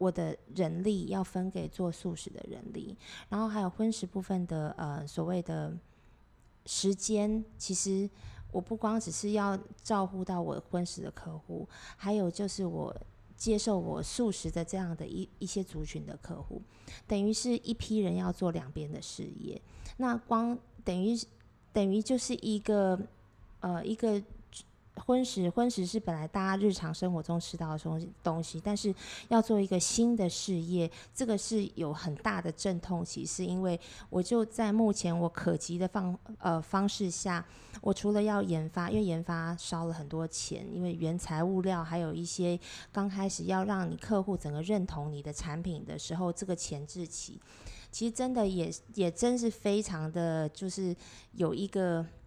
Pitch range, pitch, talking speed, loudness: 170-205 Hz, 185 Hz, 245 characters per minute, -34 LUFS